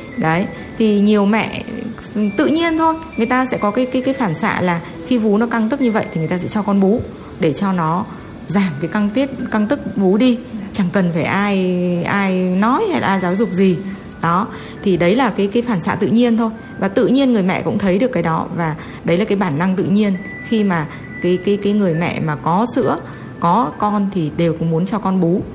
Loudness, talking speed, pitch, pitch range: -17 LUFS, 240 wpm, 200 Hz, 175-225 Hz